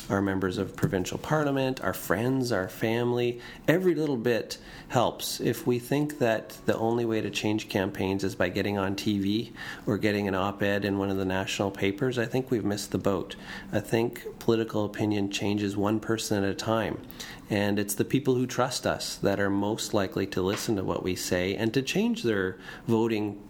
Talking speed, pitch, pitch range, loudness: 195 wpm, 105 Hz, 100-120 Hz, -28 LUFS